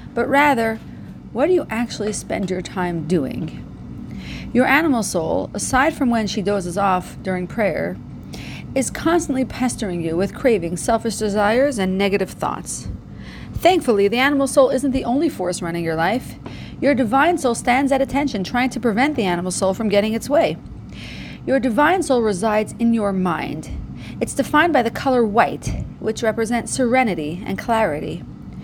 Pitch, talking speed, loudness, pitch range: 230 Hz, 160 wpm, -19 LUFS, 200-270 Hz